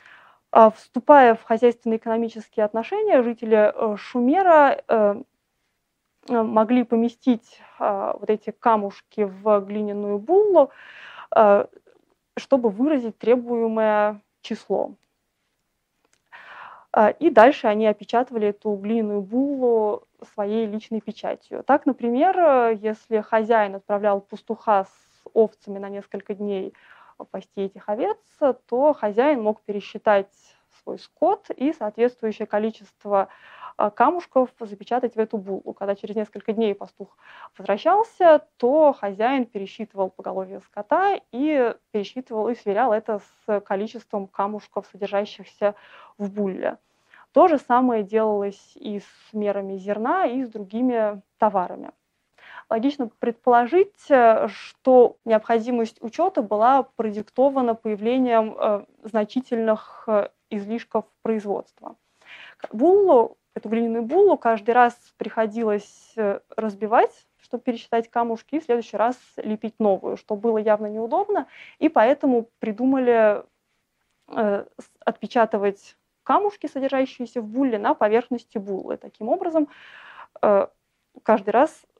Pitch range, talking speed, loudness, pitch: 210-255 Hz, 105 wpm, -22 LUFS, 225 Hz